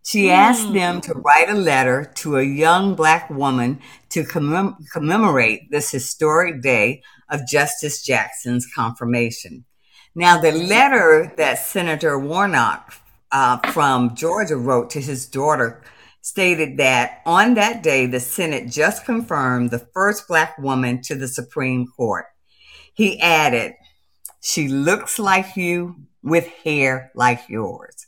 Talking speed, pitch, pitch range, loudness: 130 wpm, 150 Hz, 125-175 Hz, -18 LUFS